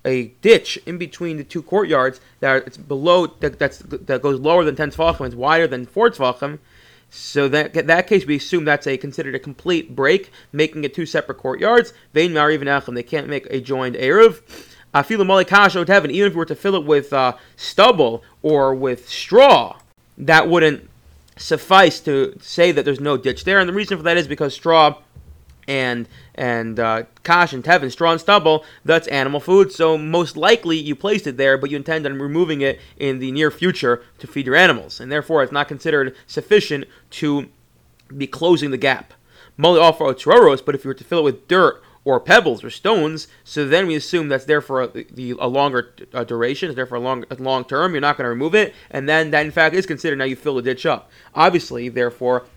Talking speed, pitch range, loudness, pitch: 205 wpm, 130-170 Hz, -17 LUFS, 150 Hz